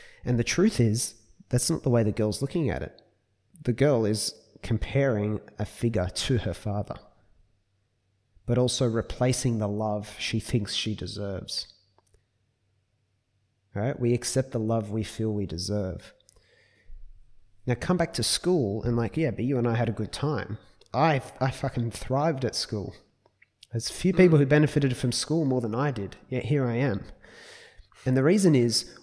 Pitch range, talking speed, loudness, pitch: 105-130 Hz, 170 wpm, -27 LUFS, 115 Hz